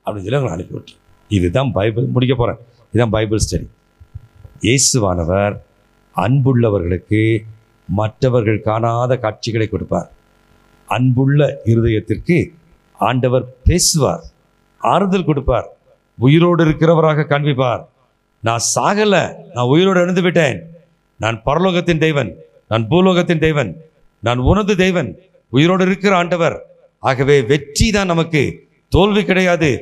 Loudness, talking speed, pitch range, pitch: -15 LUFS, 100 wpm, 110-170 Hz, 130 Hz